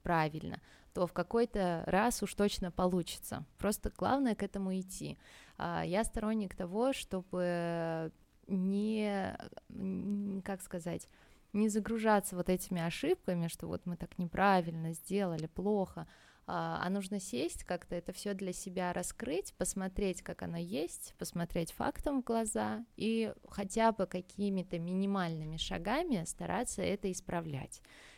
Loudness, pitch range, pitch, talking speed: -36 LUFS, 175-205 Hz, 190 Hz, 125 wpm